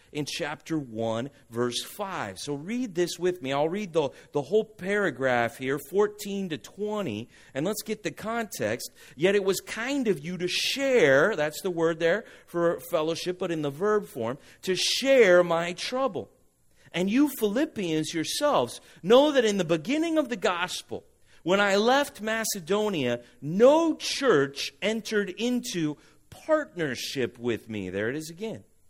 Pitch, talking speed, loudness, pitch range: 180 Hz, 155 wpm, -27 LUFS, 150-220 Hz